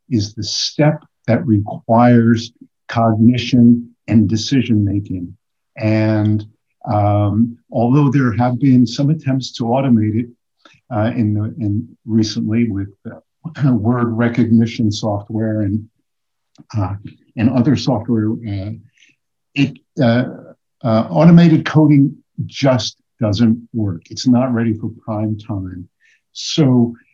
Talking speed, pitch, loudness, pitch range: 115 wpm, 115 Hz, -16 LUFS, 110-125 Hz